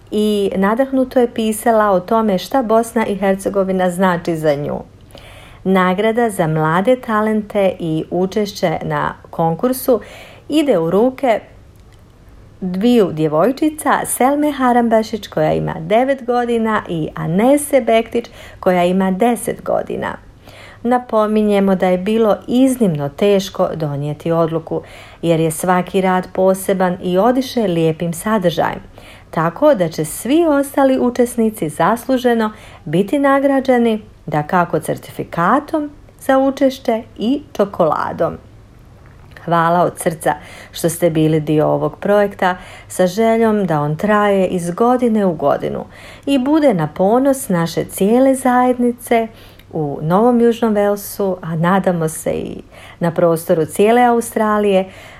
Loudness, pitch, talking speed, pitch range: -16 LUFS, 200 Hz, 120 wpm, 170-240 Hz